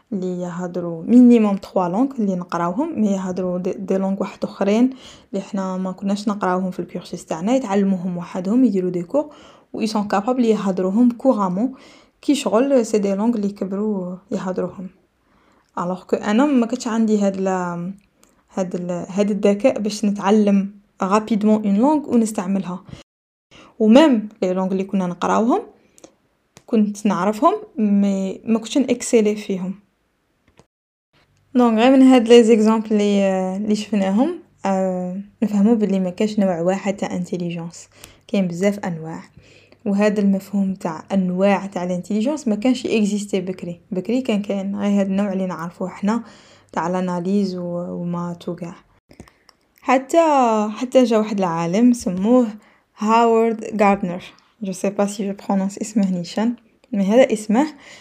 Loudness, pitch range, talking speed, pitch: -19 LUFS, 185-230 Hz, 130 wpm, 205 Hz